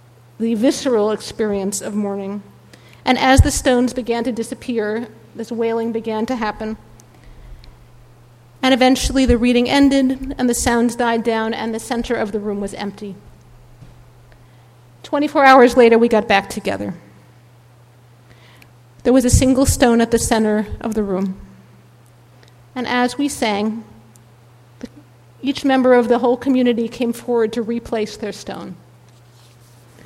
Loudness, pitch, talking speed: -17 LUFS, 220 Hz, 140 wpm